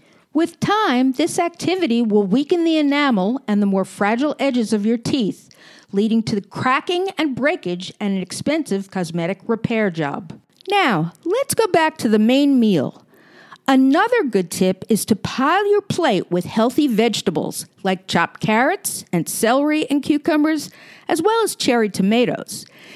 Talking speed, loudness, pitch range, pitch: 155 wpm, -19 LUFS, 200-310 Hz, 240 Hz